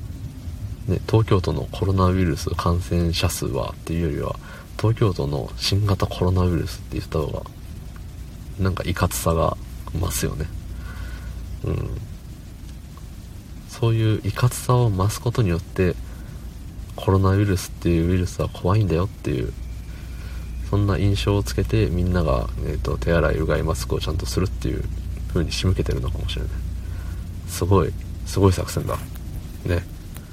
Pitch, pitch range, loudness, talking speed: 90 Hz, 85-100 Hz, -23 LUFS, 320 characters per minute